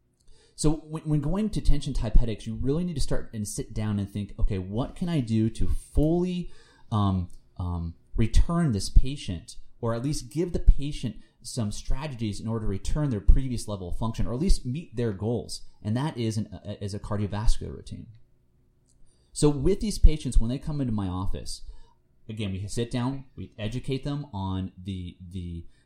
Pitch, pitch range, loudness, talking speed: 115 Hz, 100-140 Hz, -30 LUFS, 185 wpm